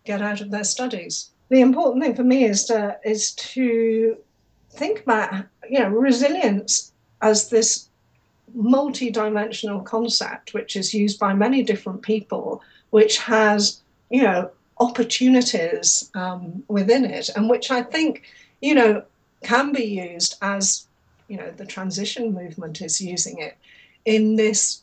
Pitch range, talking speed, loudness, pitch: 205-245 Hz, 145 wpm, -20 LUFS, 220 Hz